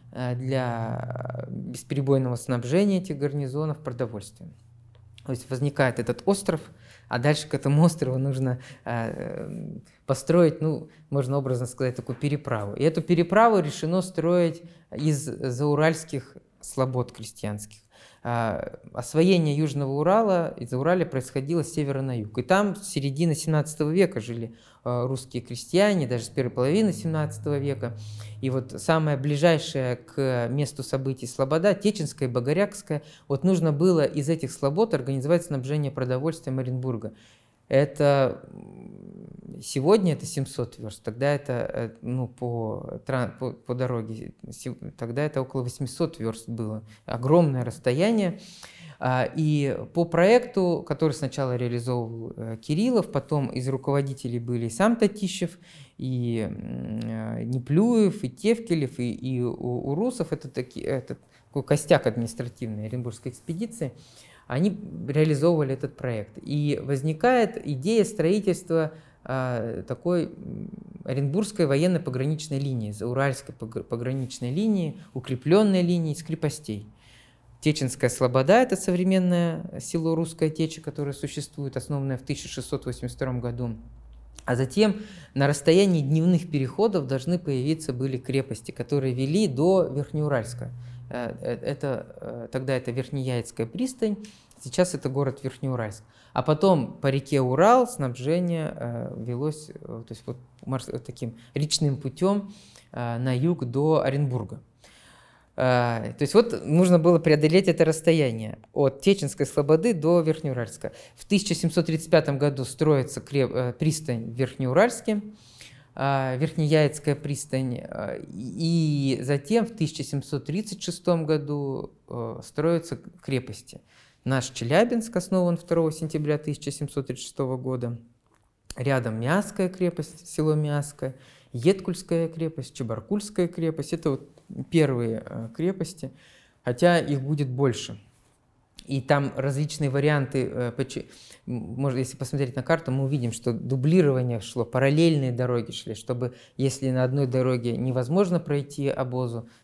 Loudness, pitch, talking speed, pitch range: -26 LUFS, 140 Hz, 110 wpm, 125-165 Hz